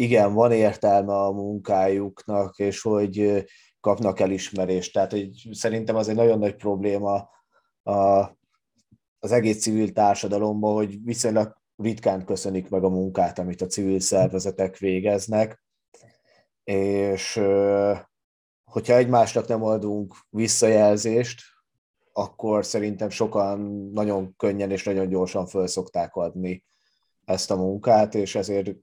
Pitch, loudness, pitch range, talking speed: 100 Hz, -23 LUFS, 95-110 Hz, 115 wpm